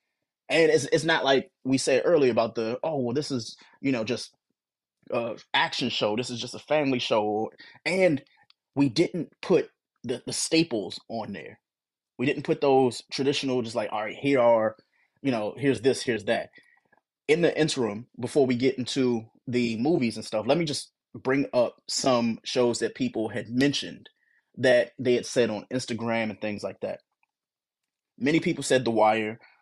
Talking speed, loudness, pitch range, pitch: 180 wpm, -26 LUFS, 115-145 Hz, 125 Hz